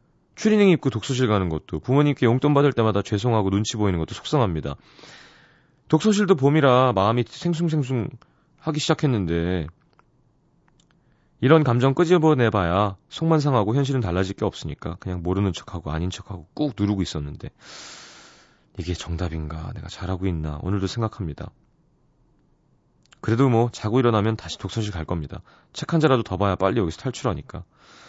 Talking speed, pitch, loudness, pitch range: 350 characters per minute, 110 Hz, -22 LUFS, 90-140 Hz